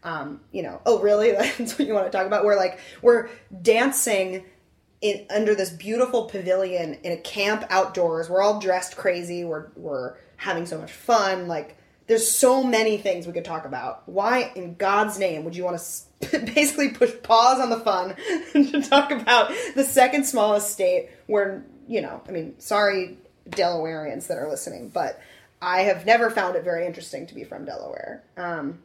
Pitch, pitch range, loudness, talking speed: 205 Hz, 180-235 Hz, -23 LUFS, 185 wpm